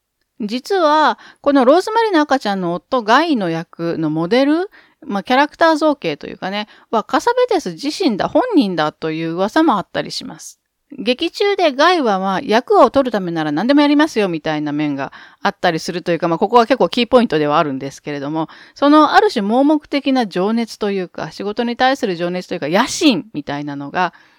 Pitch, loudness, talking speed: 230 Hz, -16 LUFS, 400 characters per minute